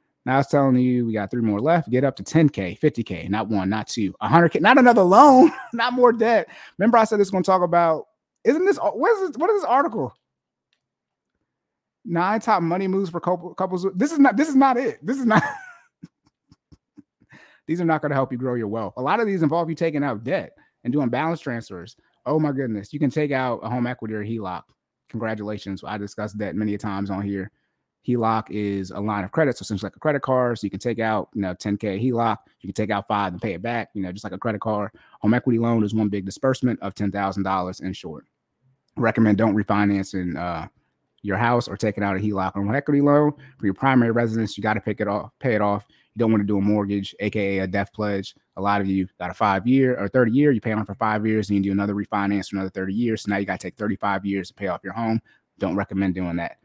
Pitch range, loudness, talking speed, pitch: 100-145 Hz, -22 LUFS, 250 wpm, 110 Hz